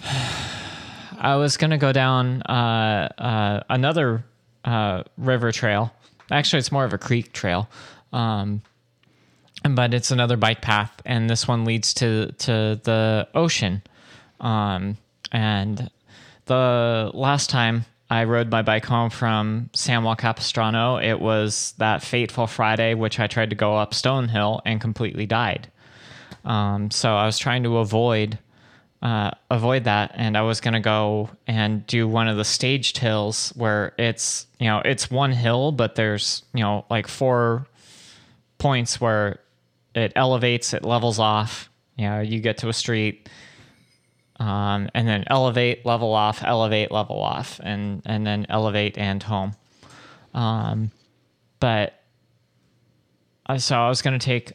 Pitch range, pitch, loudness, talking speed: 105-125 Hz, 115 Hz, -22 LUFS, 150 wpm